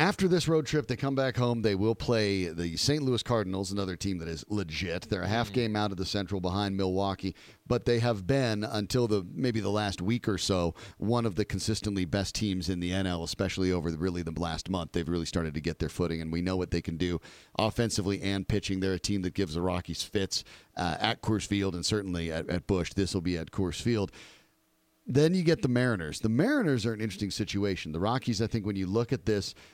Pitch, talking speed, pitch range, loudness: 100 Hz, 240 wpm, 90-115 Hz, -30 LUFS